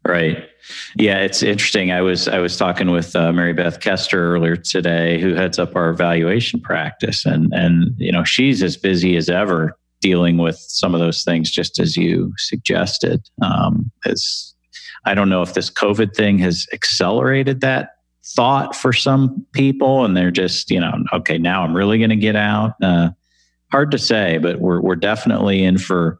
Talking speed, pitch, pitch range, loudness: 185 wpm, 90 Hz, 85-105 Hz, -17 LUFS